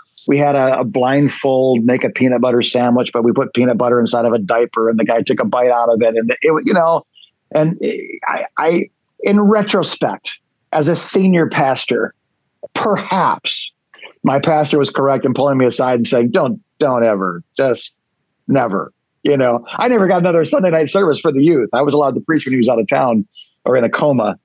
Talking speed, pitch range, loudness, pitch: 205 wpm, 120-155 Hz, -15 LUFS, 130 Hz